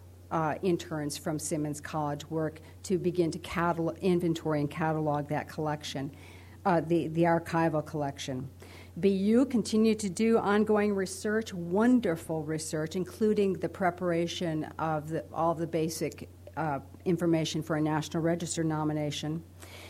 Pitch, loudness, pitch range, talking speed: 160 Hz, -30 LUFS, 150-175 Hz, 130 wpm